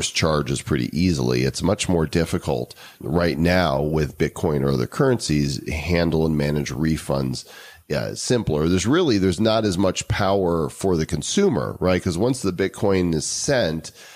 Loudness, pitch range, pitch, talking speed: -21 LUFS, 75-95 Hz, 85 Hz, 155 wpm